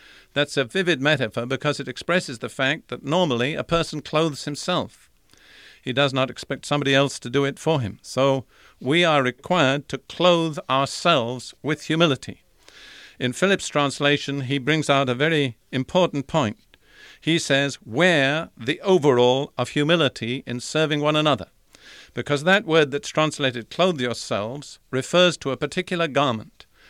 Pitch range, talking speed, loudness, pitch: 130-160 Hz, 150 wpm, -22 LUFS, 145 Hz